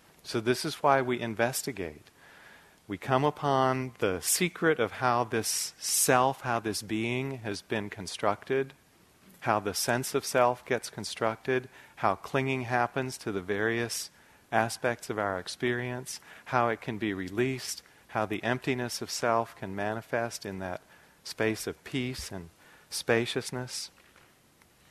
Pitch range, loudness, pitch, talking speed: 110-130 Hz, -30 LUFS, 120 Hz, 135 wpm